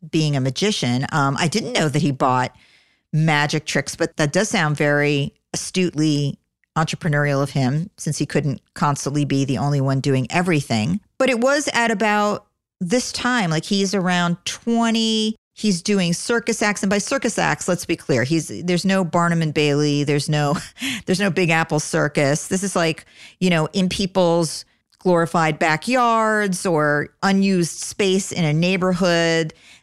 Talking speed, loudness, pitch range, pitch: 165 wpm, -20 LUFS, 150-200 Hz, 170 Hz